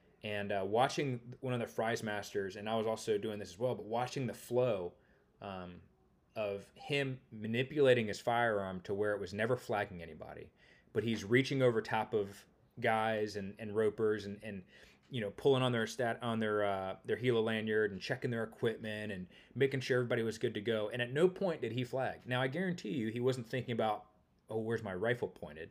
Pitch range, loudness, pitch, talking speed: 105-125 Hz, -36 LUFS, 115 Hz, 210 wpm